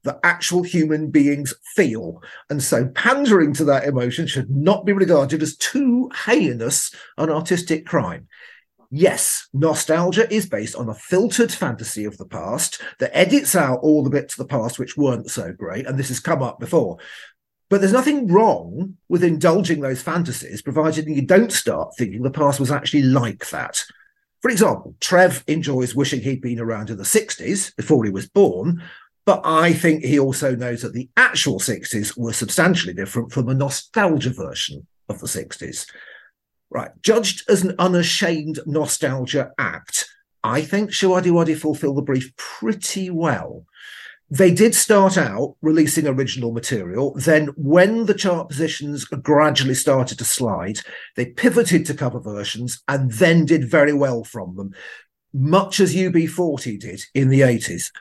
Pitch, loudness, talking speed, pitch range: 150 Hz, -19 LUFS, 160 wpm, 130-180 Hz